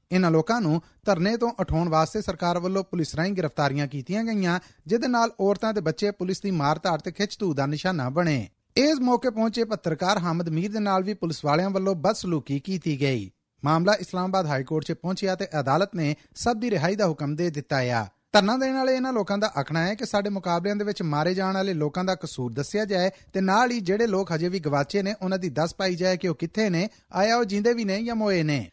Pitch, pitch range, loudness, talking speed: 185 Hz, 160-205 Hz, -25 LUFS, 220 wpm